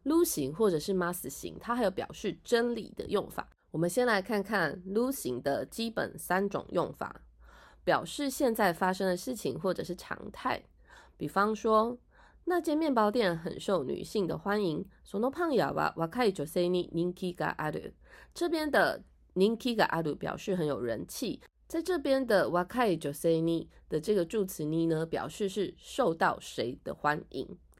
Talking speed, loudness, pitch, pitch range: 240 characters per minute, -31 LUFS, 195 Hz, 170-240 Hz